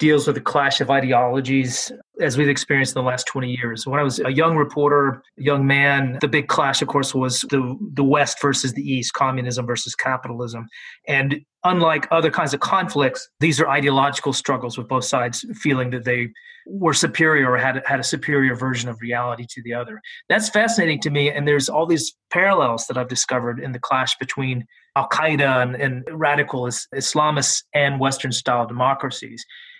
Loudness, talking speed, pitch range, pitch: -20 LUFS, 180 wpm, 125-150 Hz, 140 Hz